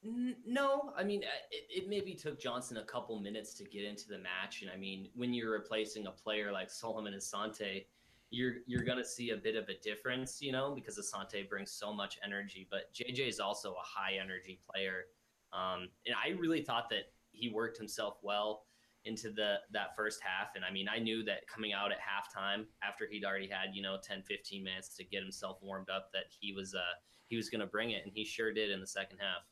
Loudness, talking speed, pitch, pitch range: -40 LUFS, 220 wpm, 110 Hz, 95-120 Hz